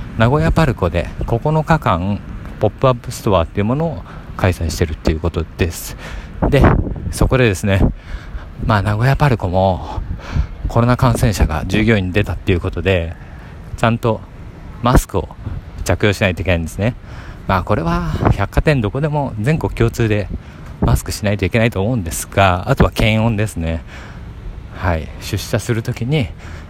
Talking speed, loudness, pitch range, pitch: 330 characters per minute, -17 LUFS, 90-115 Hz, 100 Hz